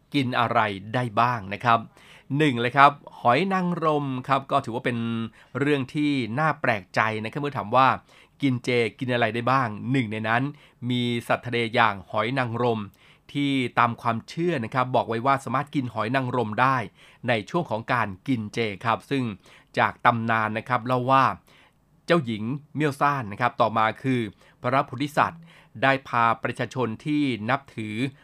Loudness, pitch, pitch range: -24 LUFS, 125 Hz, 115-140 Hz